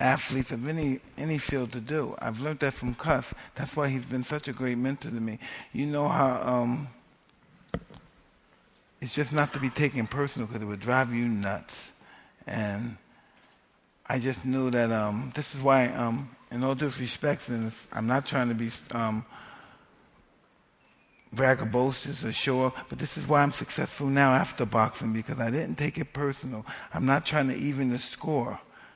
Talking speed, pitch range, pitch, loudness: 175 wpm, 120-145 Hz, 130 Hz, -29 LUFS